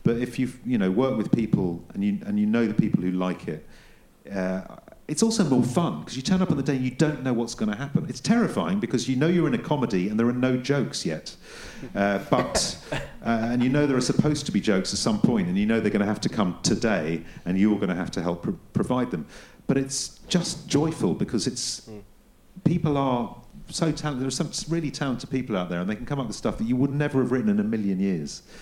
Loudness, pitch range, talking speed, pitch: -25 LUFS, 110-165 Hz, 260 wpm, 130 Hz